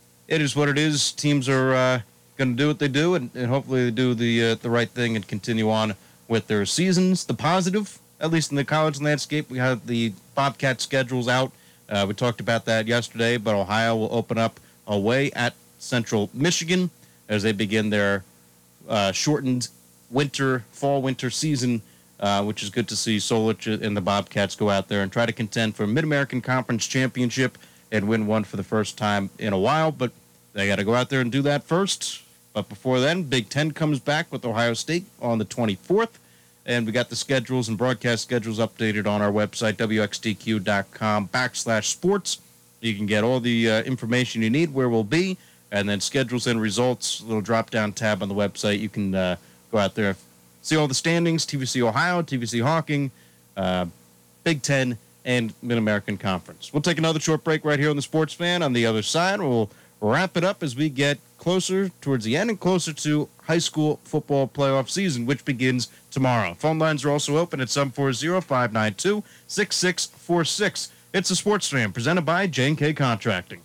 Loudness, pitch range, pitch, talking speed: -24 LUFS, 105-145 Hz, 120 Hz, 200 wpm